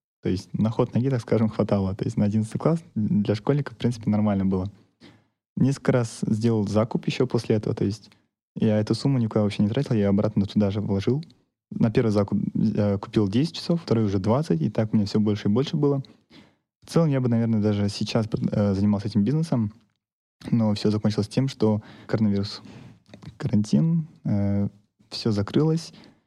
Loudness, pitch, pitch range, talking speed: -24 LUFS, 110 Hz, 105-130 Hz, 180 wpm